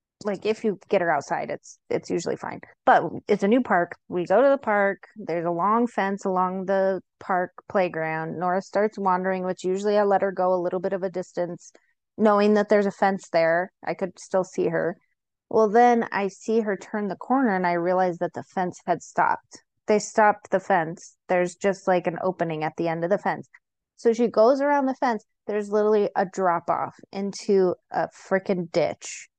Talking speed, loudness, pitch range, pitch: 205 wpm, -24 LUFS, 180-210 Hz, 195 Hz